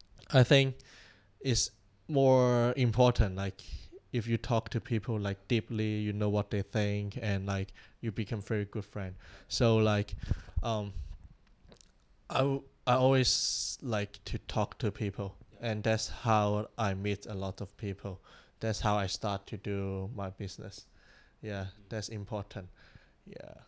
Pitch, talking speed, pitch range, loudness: 105 Hz, 145 wpm, 100-115 Hz, -32 LUFS